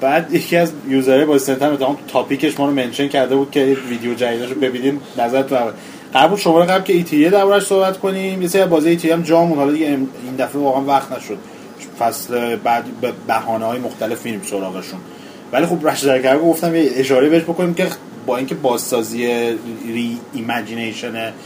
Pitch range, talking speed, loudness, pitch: 120-165 Hz, 180 wpm, -17 LUFS, 135 Hz